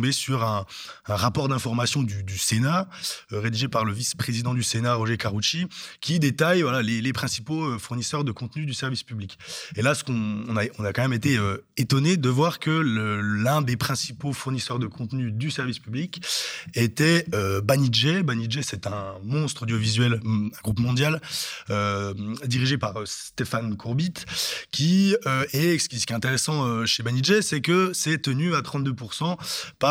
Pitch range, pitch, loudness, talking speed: 115-150 Hz, 125 Hz, -25 LUFS, 180 wpm